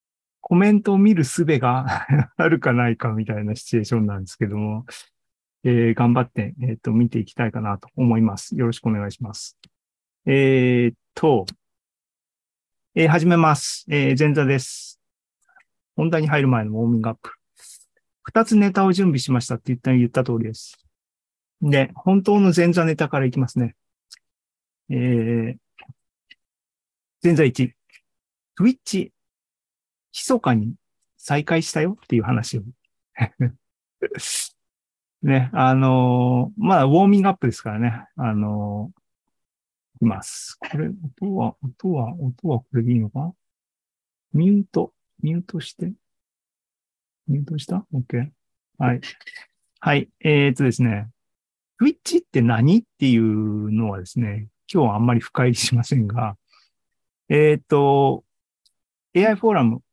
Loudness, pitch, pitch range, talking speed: -20 LUFS, 130 Hz, 115-160 Hz, 275 characters per minute